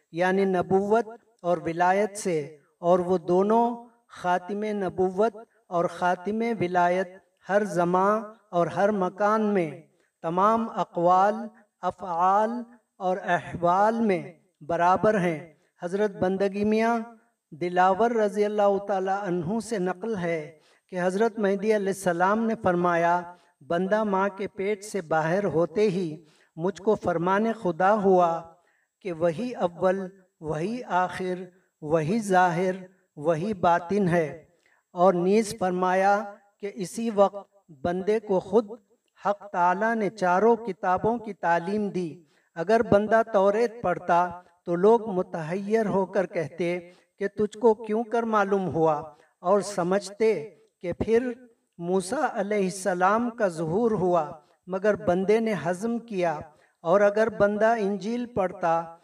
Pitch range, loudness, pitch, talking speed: 175-215 Hz, -25 LUFS, 190 Hz, 125 wpm